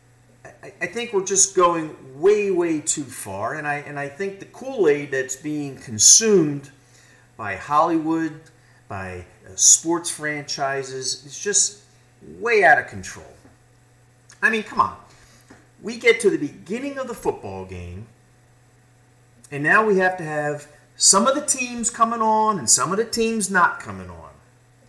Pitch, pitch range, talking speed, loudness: 140 Hz, 125-195 Hz, 155 wpm, -19 LUFS